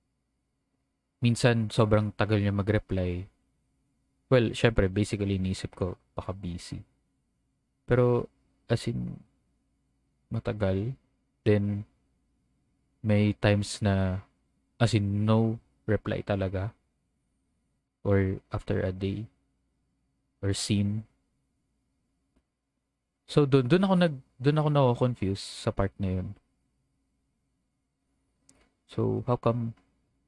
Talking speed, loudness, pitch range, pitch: 90 wpm, -28 LUFS, 95-120 Hz, 105 Hz